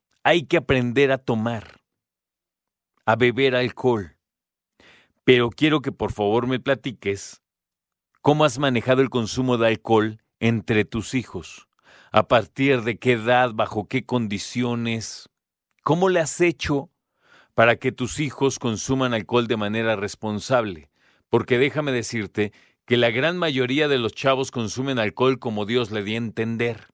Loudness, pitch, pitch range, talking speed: -22 LUFS, 120 Hz, 110-135 Hz, 145 wpm